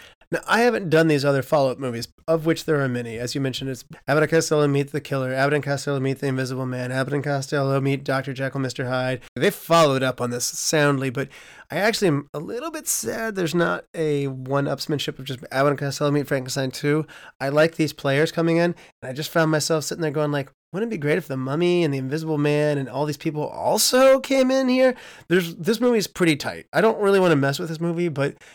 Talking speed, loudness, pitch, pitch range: 240 wpm, -22 LUFS, 150 Hz, 135-165 Hz